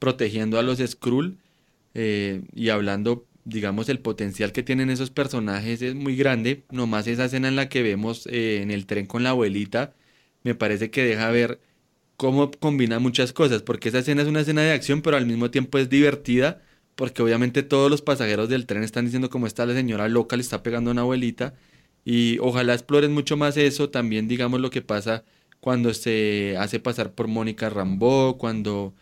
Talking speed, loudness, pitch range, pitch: 190 wpm, -23 LUFS, 110-130 Hz, 120 Hz